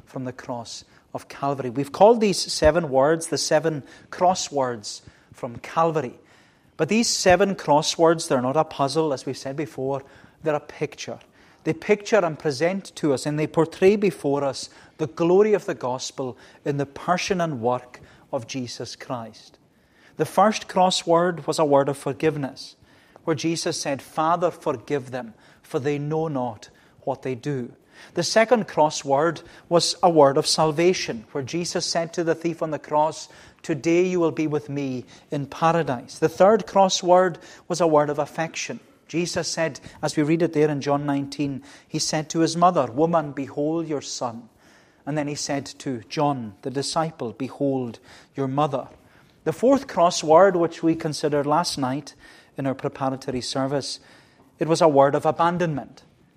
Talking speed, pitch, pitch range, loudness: 165 wpm, 155 Hz, 140-170 Hz, -23 LUFS